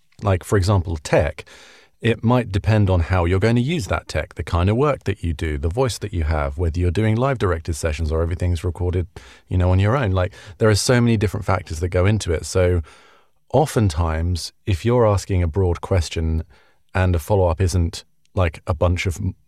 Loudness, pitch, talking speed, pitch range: -20 LUFS, 95 Hz, 215 wpm, 85-105 Hz